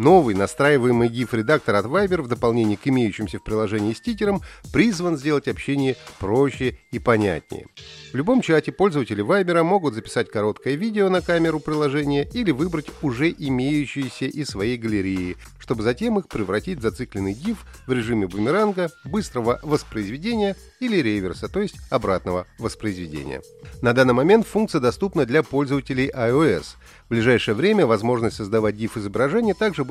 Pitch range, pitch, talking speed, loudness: 110-165 Hz, 130 Hz, 140 wpm, -22 LUFS